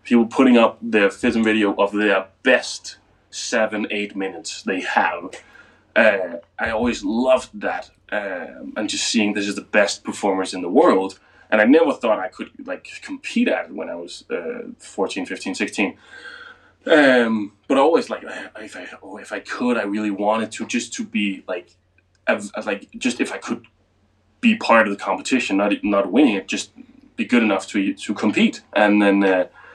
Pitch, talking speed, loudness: 110 Hz, 185 wpm, -20 LUFS